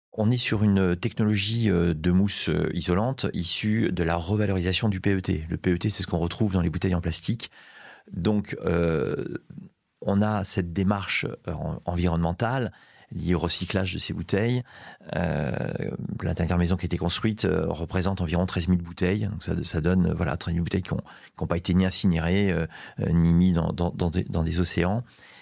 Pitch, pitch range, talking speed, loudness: 90 Hz, 85-100 Hz, 170 wpm, -26 LUFS